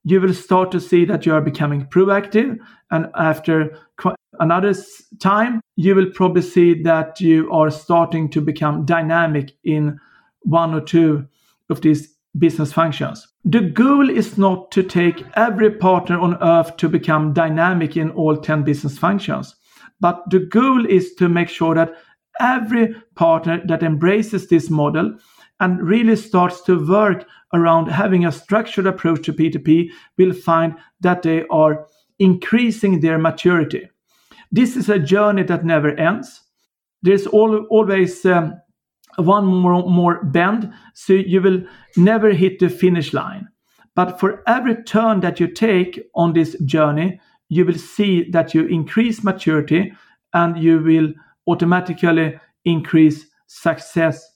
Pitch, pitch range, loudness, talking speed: 175 Hz, 165-195 Hz, -17 LUFS, 145 wpm